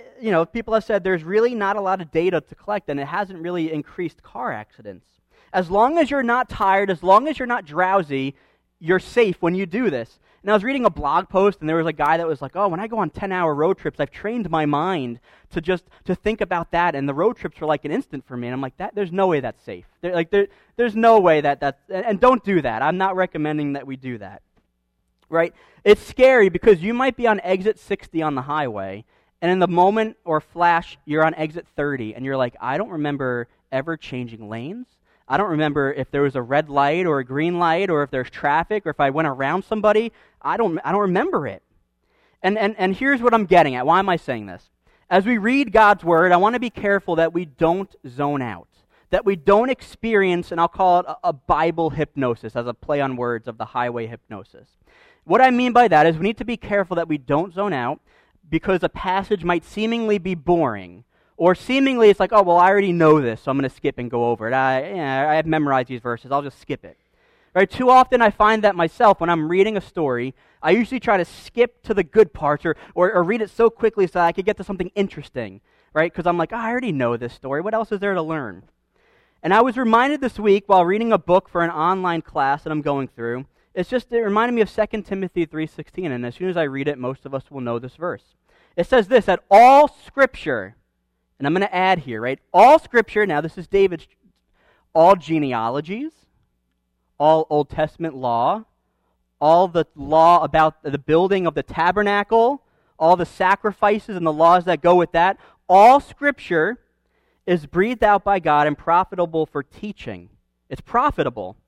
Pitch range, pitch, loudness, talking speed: 145-205 Hz, 175 Hz, -19 LUFS, 230 wpm